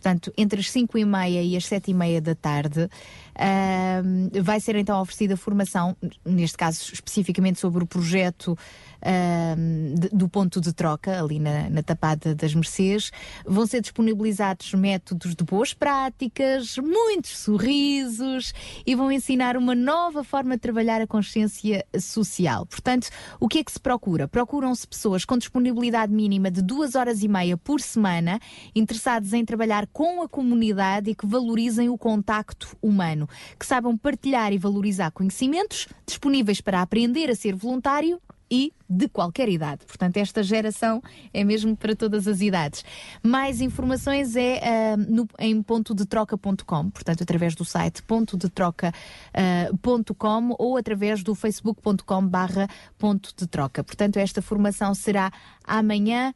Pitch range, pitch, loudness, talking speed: 185-240 Hz, 210 Hz, -24 LUFS, 145 wpm